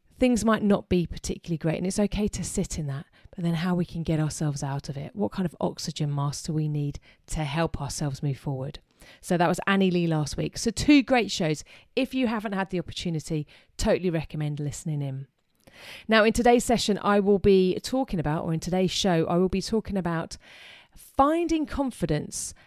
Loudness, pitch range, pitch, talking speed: -26 LUFS, 155-205 Hz, 175 Hz, 205 wpm